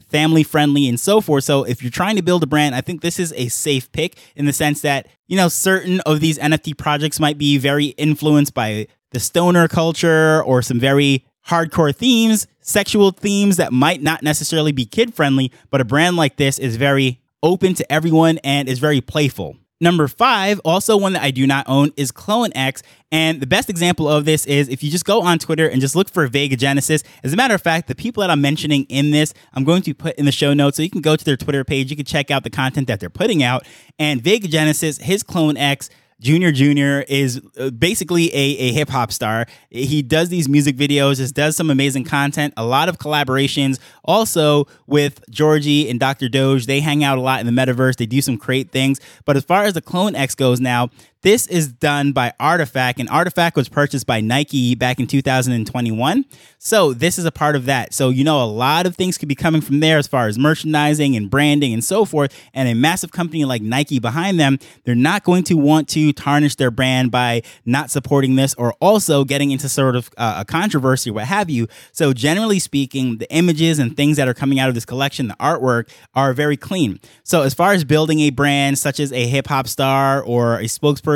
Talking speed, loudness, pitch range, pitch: 225 wpm, -17 LUFS, 130-160 Hz, 145 Hz